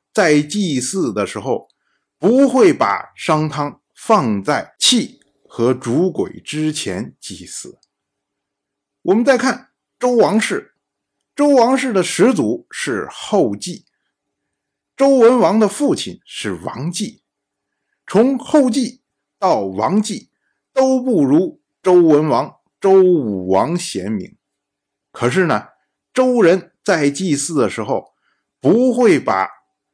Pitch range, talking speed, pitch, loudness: 160-255 Hz, 155 characters per minute, 210 Hz, -16 LUFS